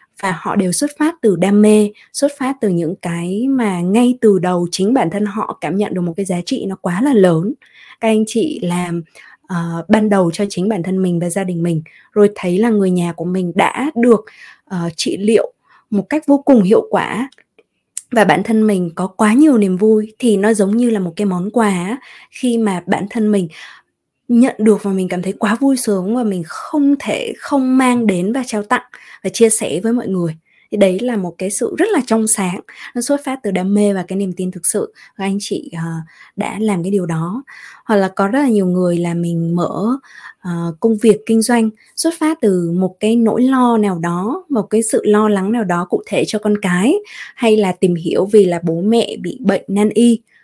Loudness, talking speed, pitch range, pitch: -15 LUFS, 230 wpm, 185-230 Hz, 210 Hz